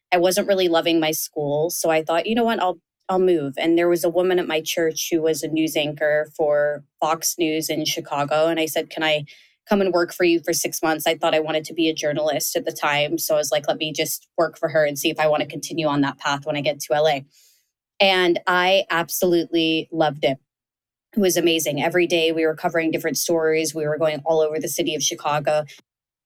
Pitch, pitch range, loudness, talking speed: 160 Hz, 155-170 Hz, -21 LUFS, 240 wpm